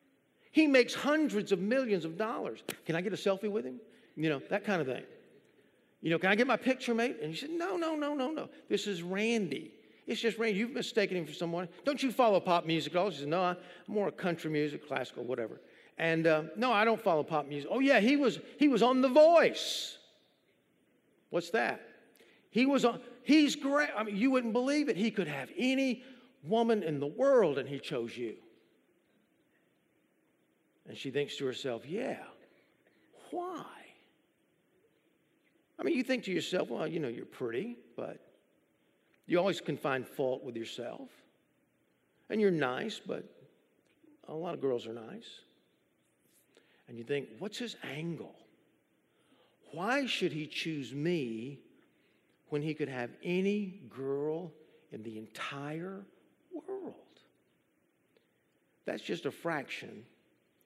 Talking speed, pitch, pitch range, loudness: 165 wpm, 205 Hz, 155-255 Hz, -32 LUFS